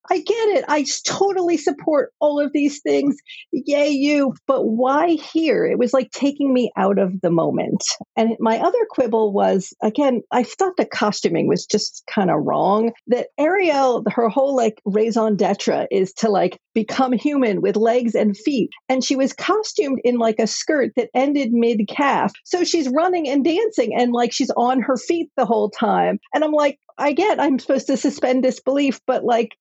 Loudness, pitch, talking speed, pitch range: -19 LUFS, 260 Hz, 185 wpm, 230-295 Hz